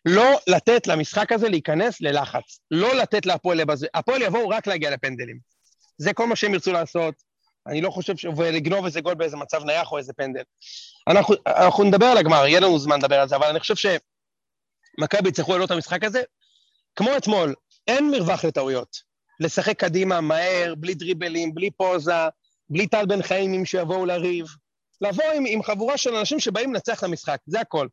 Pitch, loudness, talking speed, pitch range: 185 Hz, -22 LUFS, 185 wpm, 160-215 Hz